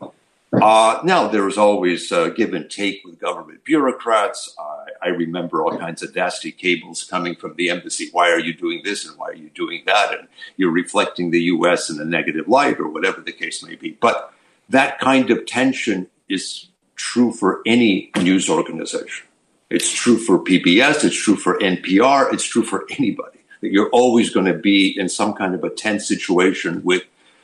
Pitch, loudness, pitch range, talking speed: 105 Hz, -18 LUFS, 90-125 Hz, 190 wpm